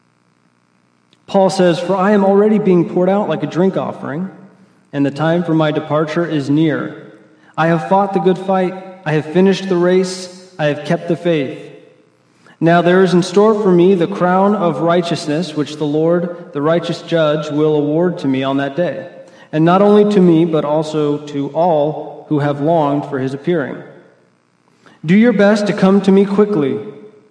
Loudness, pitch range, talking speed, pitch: -14 LUFS, 150-185 Hz, 185 wpm, 170 Hz